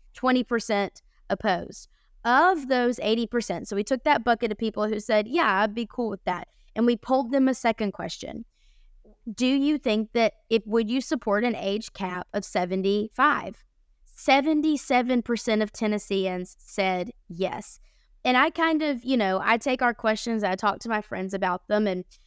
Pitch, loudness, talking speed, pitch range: 225 Hz, -25 LUFS, 170 wpm, 205-255 Hz